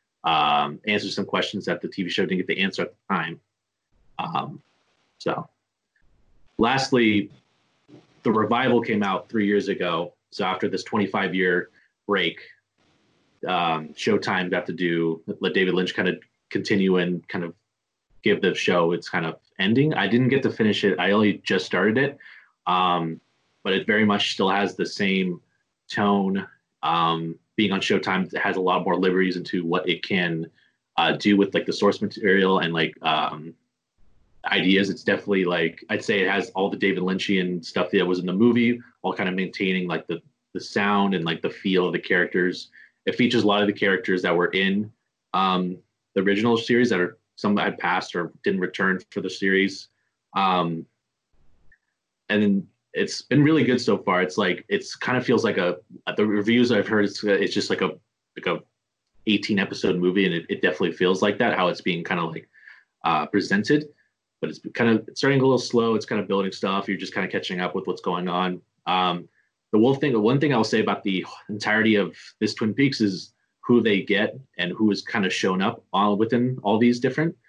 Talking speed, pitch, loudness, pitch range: 200 wpm, 100 Hz, -23 LUFS, 90-105 Hz